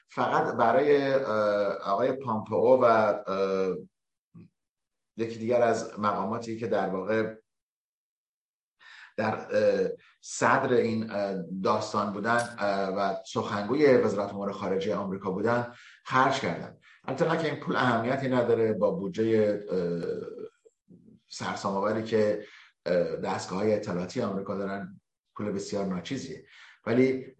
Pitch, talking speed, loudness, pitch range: 110 Hz, 95 wpm, -28 LUFS, 100-120 Hz